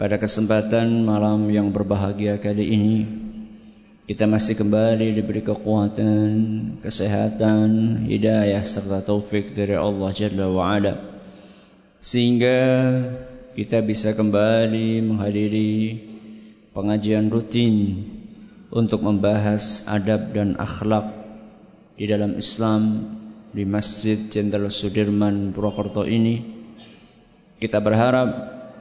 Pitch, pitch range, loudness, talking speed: 110 Hz, 105-110 Hz, -21 LUFS, 90 wpm